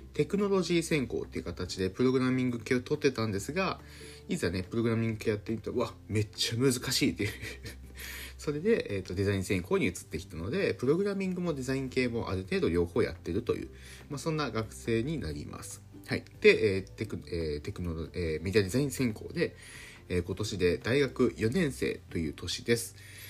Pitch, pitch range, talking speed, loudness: 110 Hz, 95-130 Hz, 410 characters per minute, -31 LUFS